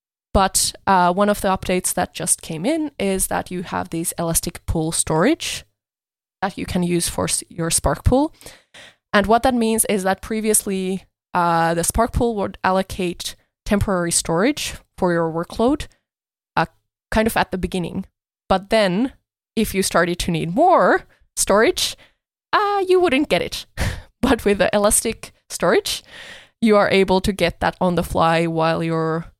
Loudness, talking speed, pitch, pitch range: -19 LUFS, 165 wpm, 190 Hz, 170-220 Hz